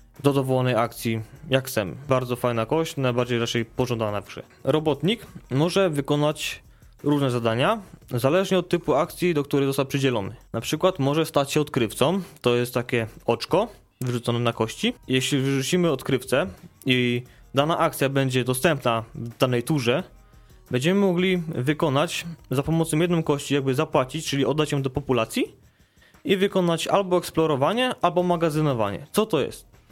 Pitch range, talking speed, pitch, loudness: 125-165 Hz, 145 wpm, 140 Hz, -24 LUFS